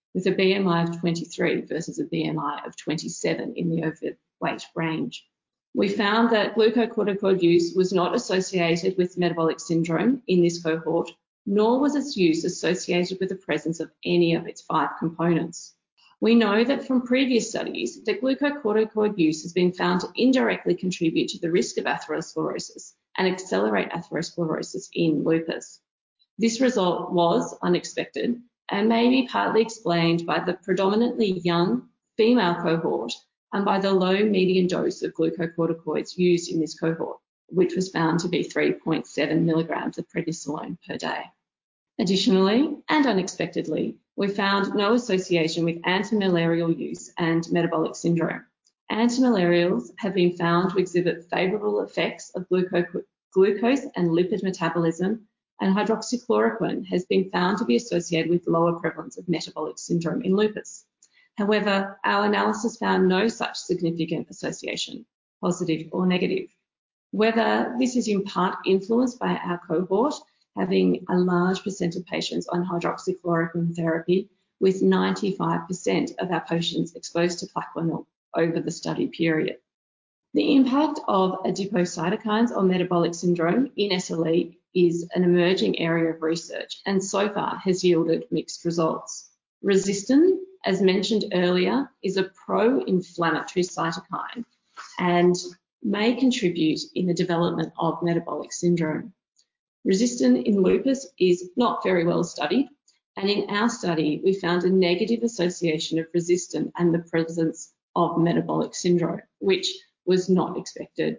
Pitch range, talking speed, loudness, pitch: 170-210 Hz, 140 wpm, -24 LUFS, 180 Hz